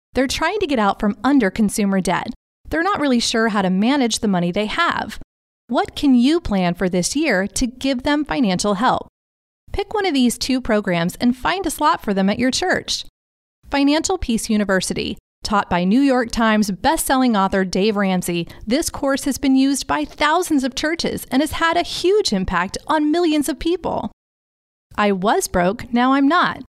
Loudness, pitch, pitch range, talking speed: -19 LUFS, 255 Hz, 205-300 Hz, 190 wpm